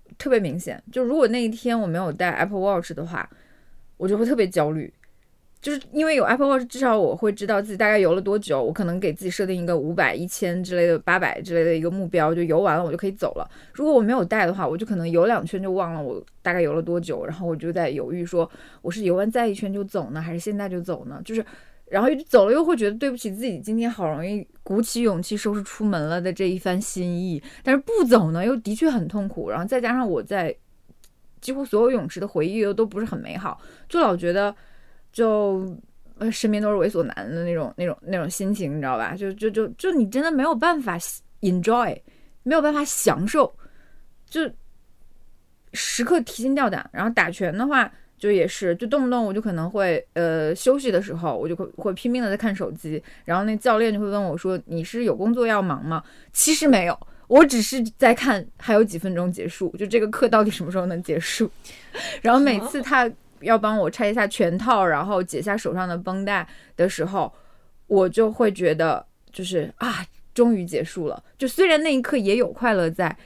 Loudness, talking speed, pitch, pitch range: -22 LUFS, 330 characters per minute, 205 Hz, 175-235 Hz